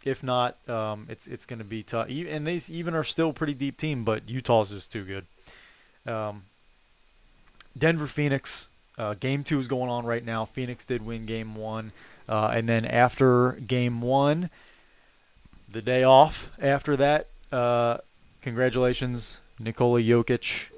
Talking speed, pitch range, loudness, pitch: 155 wpm, 115-140 Hz, -26 LUFS, 125 Hz